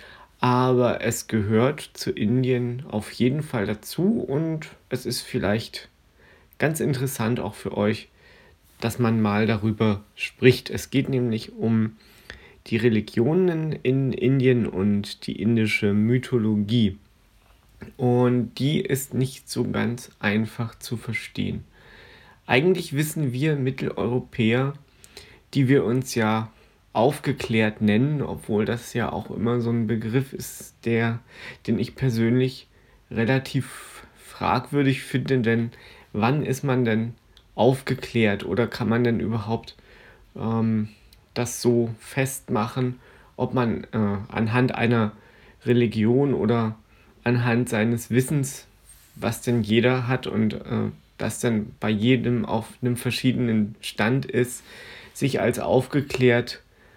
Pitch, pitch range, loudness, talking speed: 120 Hz, 110-130 Hz, -24 LUFS, 120 wpm